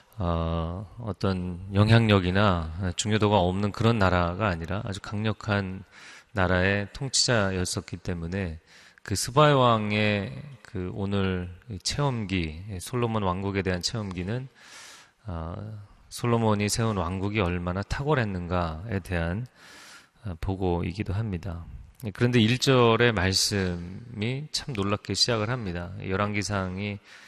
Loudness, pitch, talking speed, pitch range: -26 LUFS, 100 Hz, 255 characters per minute, 90-110 Hz